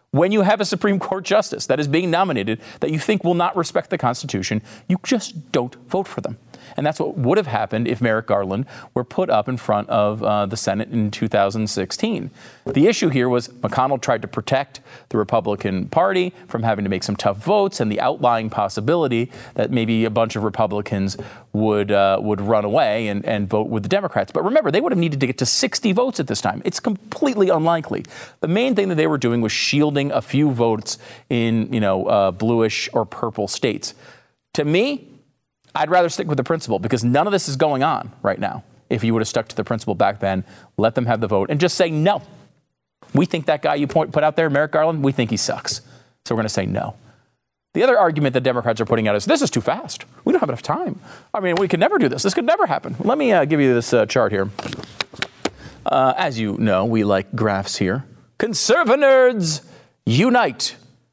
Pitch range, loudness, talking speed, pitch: 110-165 Hz, -20 LUFS, 220 wpm, 125 Hz